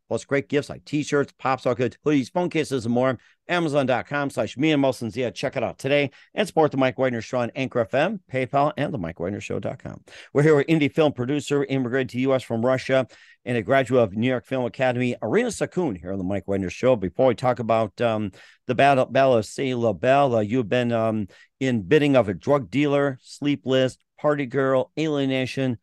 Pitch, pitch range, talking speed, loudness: 130 Hz, 120-145 Hz, 205 wpm, -23 LUFS